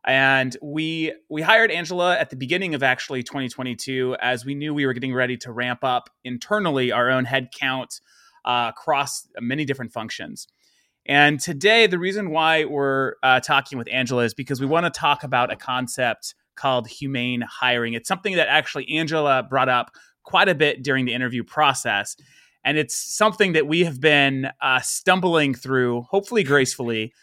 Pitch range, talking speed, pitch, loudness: 125-155 Hz, 170 wpm, 135 Hz, -21 LUFS